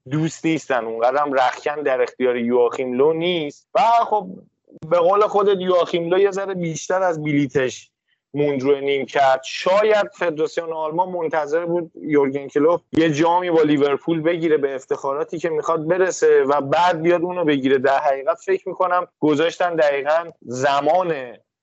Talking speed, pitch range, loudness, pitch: 150 wpm, 140-180 Hz, -19 LUFS, 160 Hz